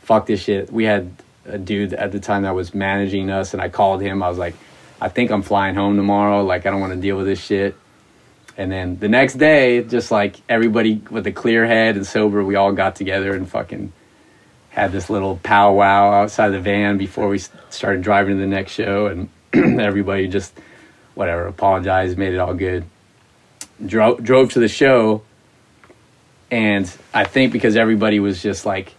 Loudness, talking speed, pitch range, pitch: -17 LUFS, 195 wpm, 95-110 Hz, 100 Hz